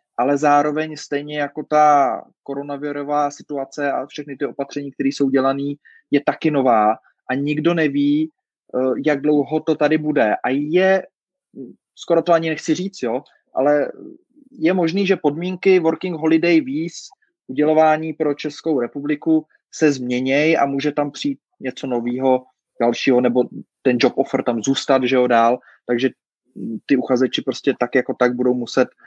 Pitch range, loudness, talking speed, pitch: 135-160 Hz, -19 LUFS, 150 wpm, 145 Hz